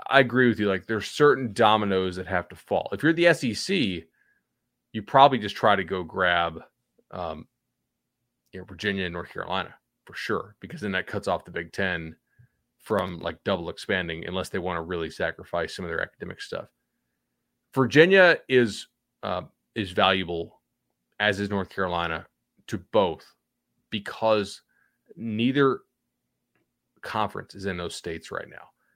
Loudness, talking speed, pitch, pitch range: -25 LUFS, 155 wpm, 100 Hz, 90-125 Hz